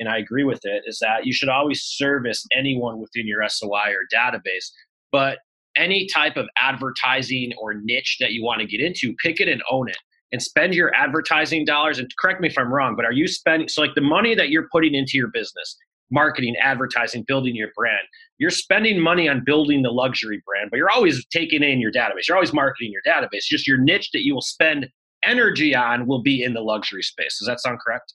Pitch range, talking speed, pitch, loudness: 120-165 Hz, 220 wpm, 135 Hz, -20 LUFS